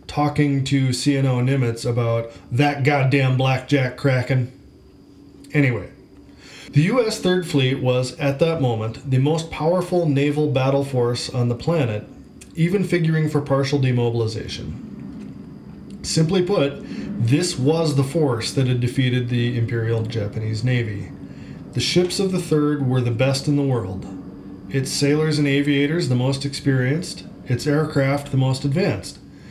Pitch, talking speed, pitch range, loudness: 135 Hz, 140 wpm, 120-150 Hz, -21 LUFS